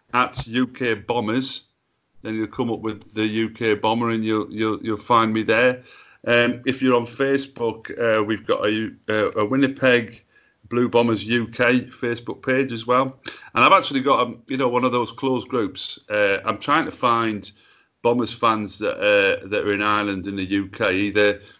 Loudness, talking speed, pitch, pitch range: -21 LUFS, 185 wpm, 115 Hz, 110-125 Hz